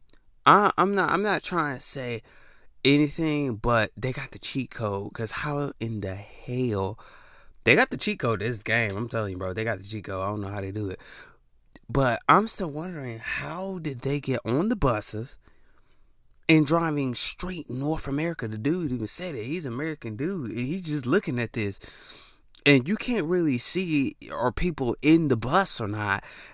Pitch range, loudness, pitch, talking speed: 110-155 Hz, -26 LUFS, 130 Hz, 195 wpm